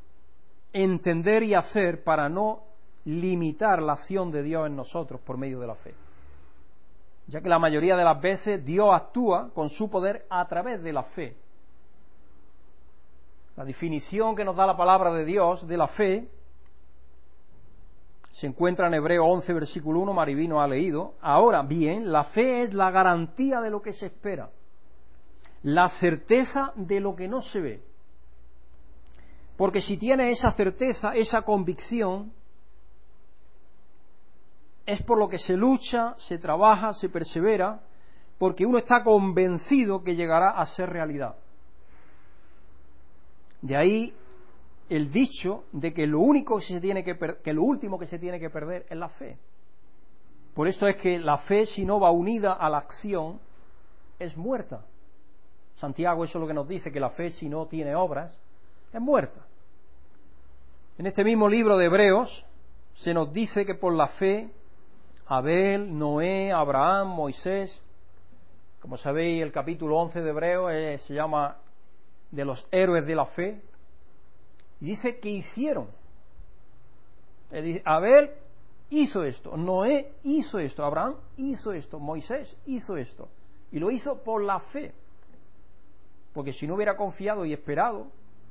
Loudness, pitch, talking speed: -26 LUFS, 165 Hz, 150 wpm